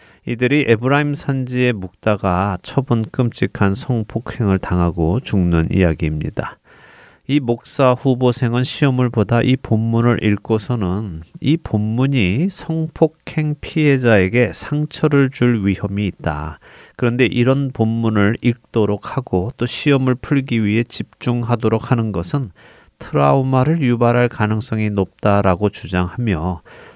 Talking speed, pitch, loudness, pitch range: 275 characters per minute, 120 Hz, -18 LUFS, 100-130 Hz